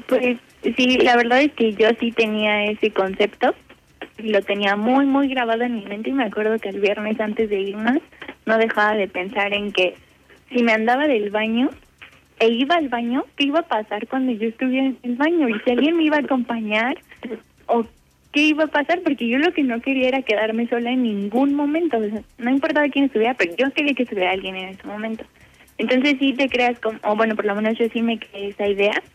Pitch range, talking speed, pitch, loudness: 215-270 Hz, 220 wpm, 235 Hz, -20 LUFS